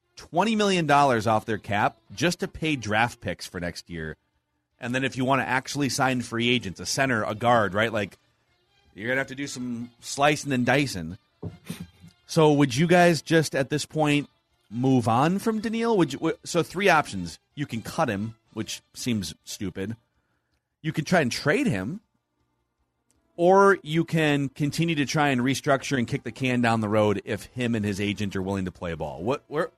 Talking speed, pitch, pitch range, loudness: 195 wpm, 125 Hz, 105-145 Hz, -25 LUFS